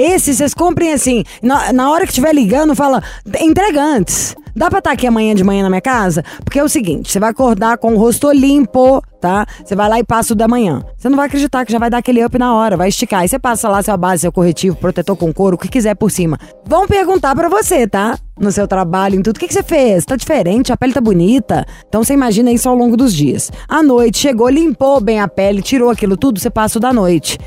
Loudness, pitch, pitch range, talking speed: -12 LUFS, 240 Hz, 200-275 Hz, 255 wpm